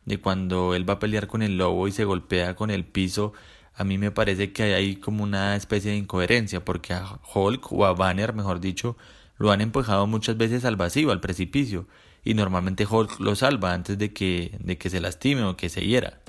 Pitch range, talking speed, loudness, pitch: 90-105 Hz, 215 wpm, -25 LUFS, 100 Hz